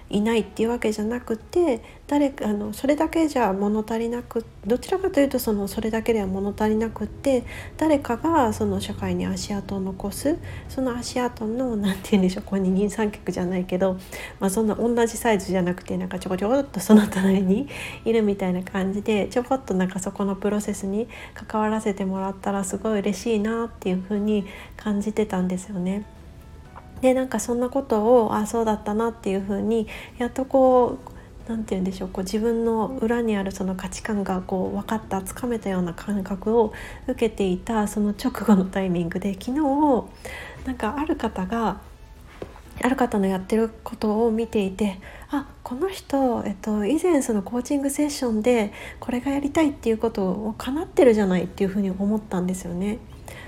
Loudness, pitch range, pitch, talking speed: -24 LUFS, 195-240 Hz, 215 Hz, 390 characters per minute